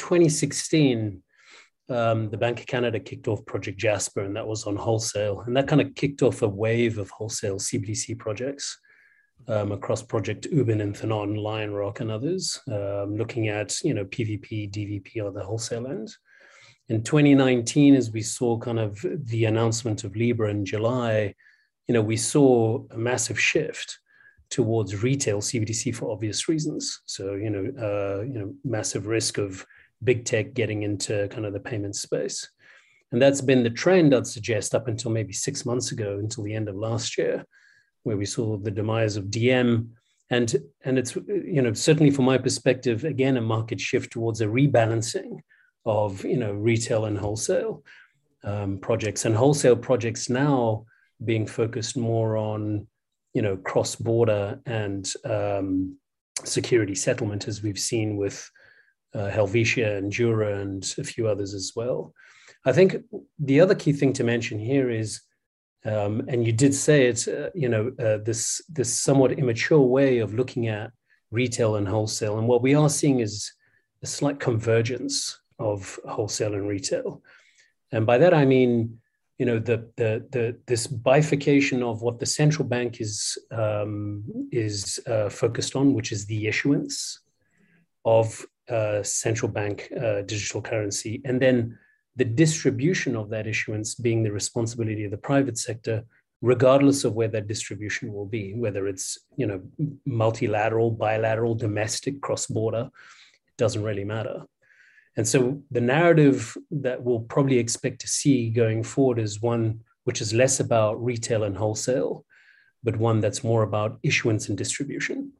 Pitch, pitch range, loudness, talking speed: 115 Hz, 110-130 Hz, -25 LUFS, 160 wpm